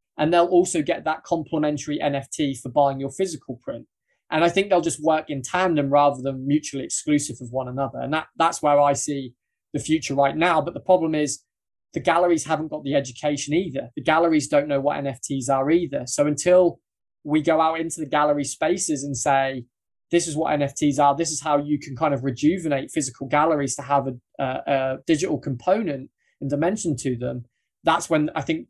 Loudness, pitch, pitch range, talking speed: -22 LUFS, 150 Hz, 140-160 Hz, 205 wpm